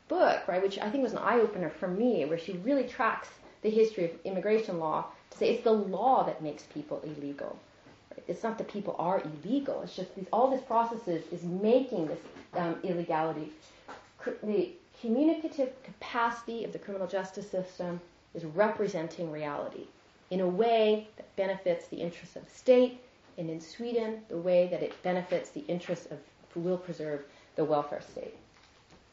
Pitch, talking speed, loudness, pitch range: 190 Hz, 180 wpm, -31 LUFS, 170-230 Hz